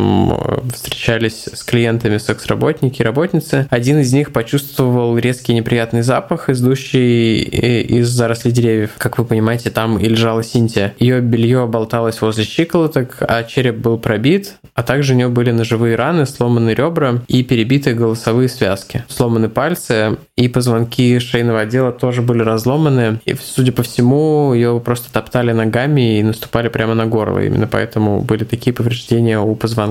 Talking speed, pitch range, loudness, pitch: 150 wpm, 115-130 Hz, -15 LUFS, 120 Hz